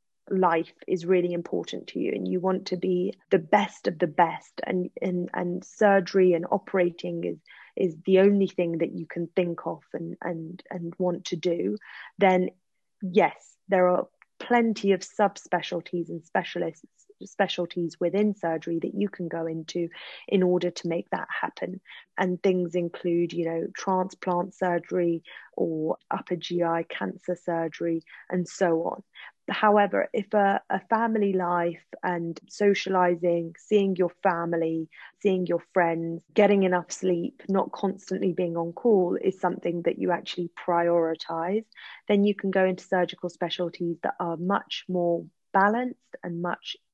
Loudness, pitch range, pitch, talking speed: -27 LUFS, 170-190 Hz, 180 Hz, 150 wpm